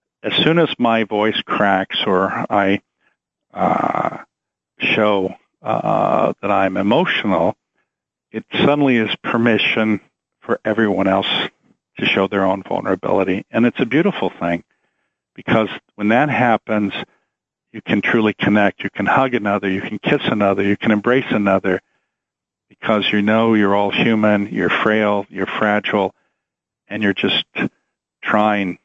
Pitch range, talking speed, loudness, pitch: 100-115 Hz, 135 wpm, -17 LUFS, 105 Hz